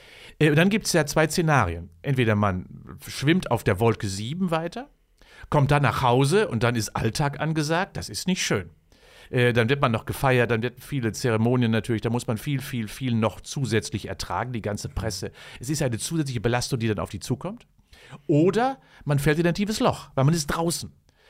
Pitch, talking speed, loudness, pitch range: 125 Hz, 200 wpm, -24 LUFS, 110-155 Hz